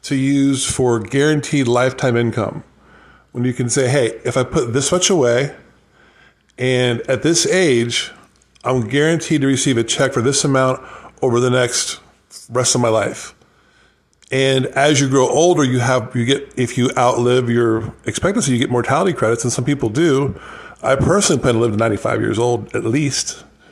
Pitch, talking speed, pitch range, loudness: 130 Hz, 175 wpm, 120-140 Hz, -16 LUFS